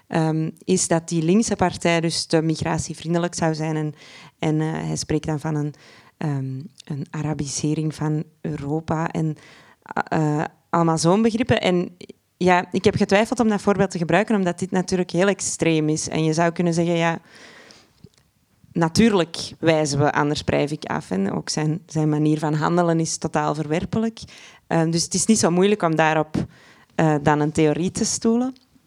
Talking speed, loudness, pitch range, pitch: 175 wpm, -21 LUFS, 155-180 Hz, 165 Hz